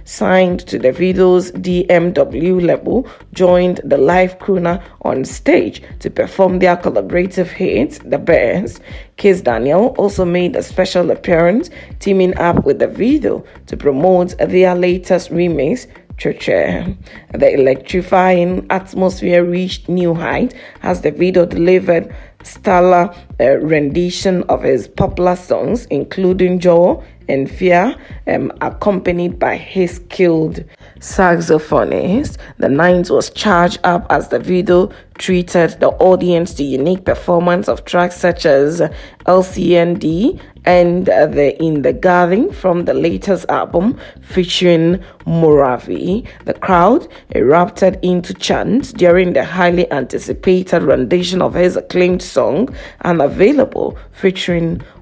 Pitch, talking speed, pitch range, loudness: 180 Hz, 120 wpm, 175-185 Hz, -14 LUFS